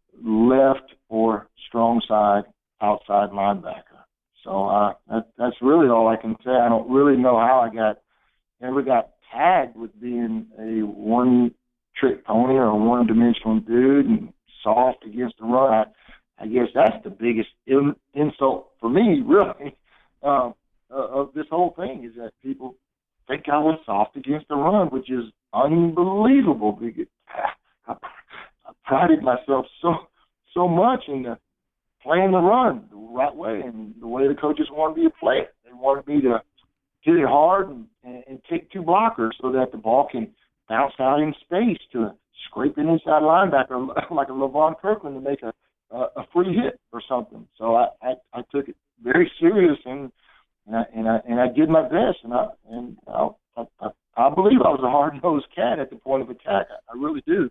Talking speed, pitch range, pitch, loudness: 185 wpm, 115-155 Hz, 130 Hz, -21 LUFS